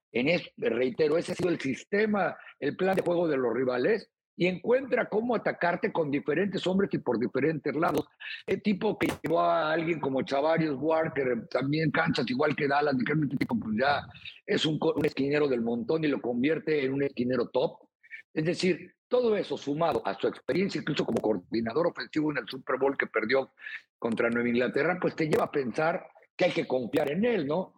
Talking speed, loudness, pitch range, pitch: 190 wpm, -28 LUFS, 140-180 Hz, 160 Hz